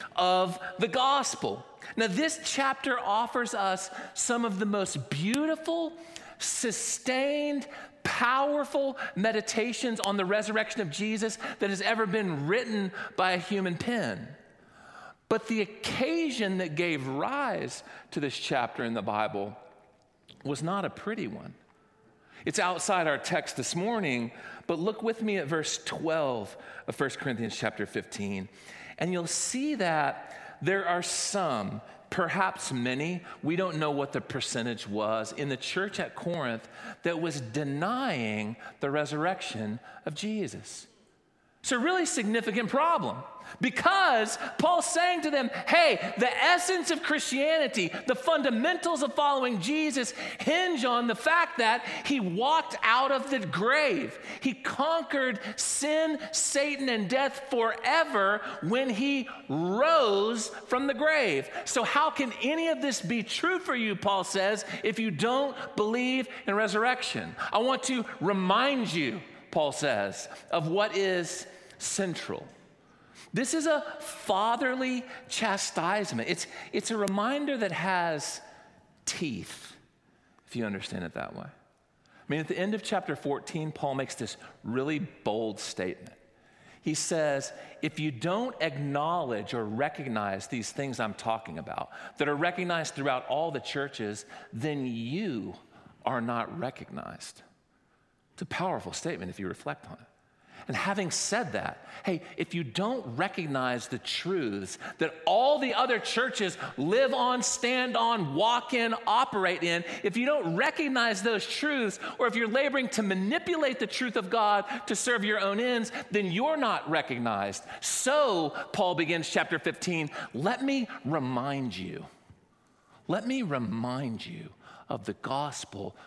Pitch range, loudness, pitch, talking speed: 160-260 Hz, -29 LUFS, 210 Hz, 140 wpm